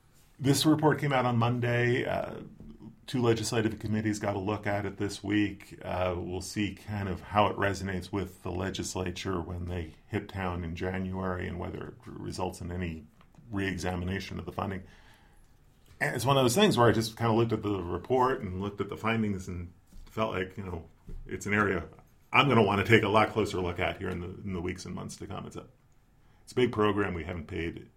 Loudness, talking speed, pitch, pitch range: -30 LUFS, 220 wpm, 100 Hz, 90-110 Hz